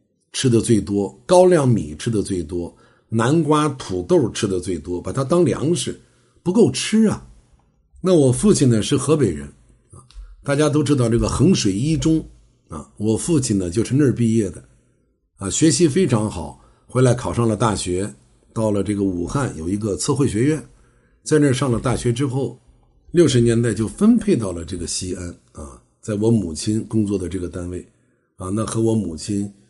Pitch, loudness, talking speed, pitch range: 115 Hz, -19 LUFS, 255 characters per minute, 95-145 Hz